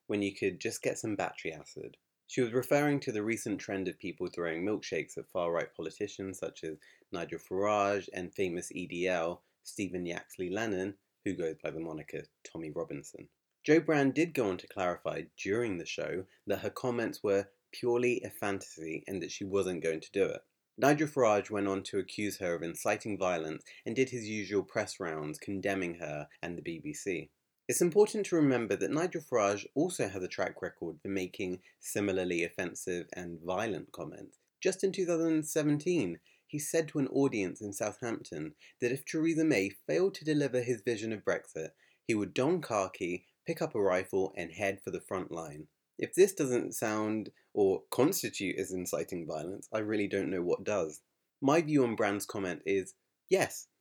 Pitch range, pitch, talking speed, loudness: 95-140 Hz, 105 Hz, 180 wpm, -33 LUFS